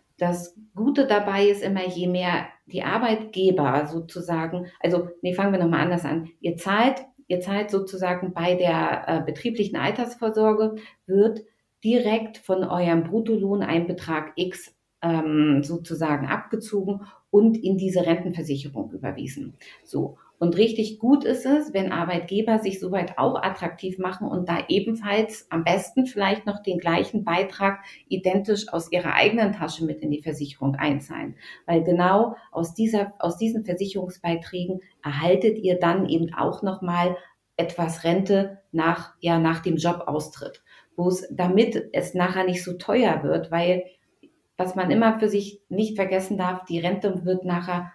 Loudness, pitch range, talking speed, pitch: -24 LUFS, 170-205 Hz, 150 wpm, 185 Hz